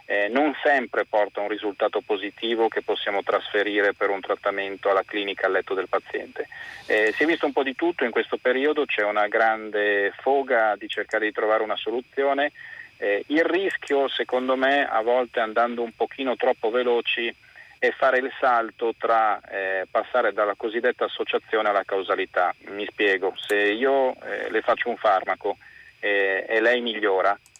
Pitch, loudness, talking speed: 125 Hz, -23 LUFS, 165 wpm